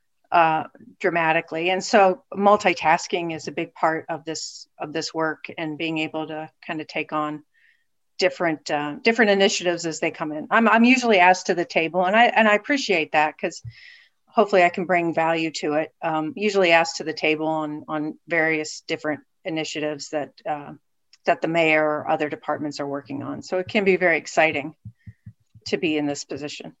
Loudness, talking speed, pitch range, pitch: -22 LUFS, 190 wpm, 155-185 Hz, 160 Hz